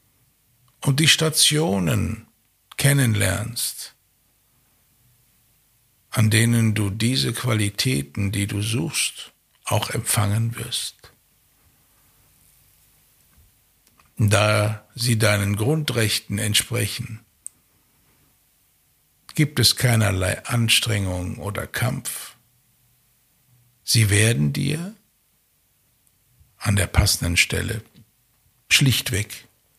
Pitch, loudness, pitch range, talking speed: 115 Hz, -21 LUFS, 105-125 Hz, 70 wpm